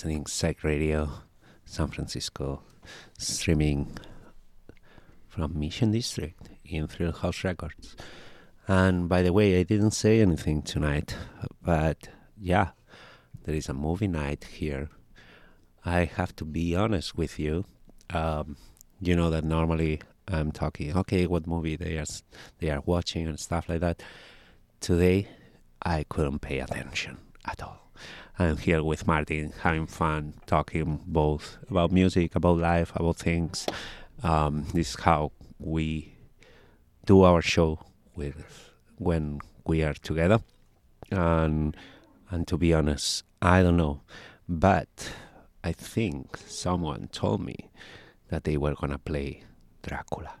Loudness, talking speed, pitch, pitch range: -28 LUFS, 130 wpm, 85 Hz, 75-90 Hz